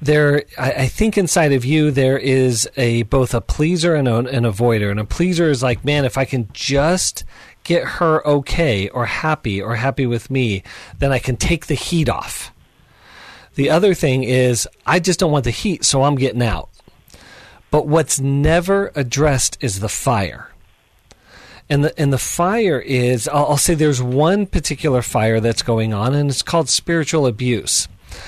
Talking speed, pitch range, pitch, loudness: 175 wpm, 120-155 Hz, 135 Hz, -17 LUFS